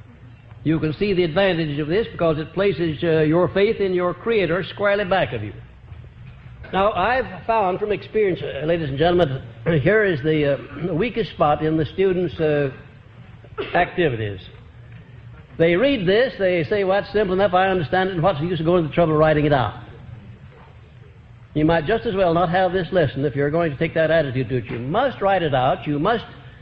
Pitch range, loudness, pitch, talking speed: 135-190 Hz, -20 LUFS, 165 Hz, 205 wpm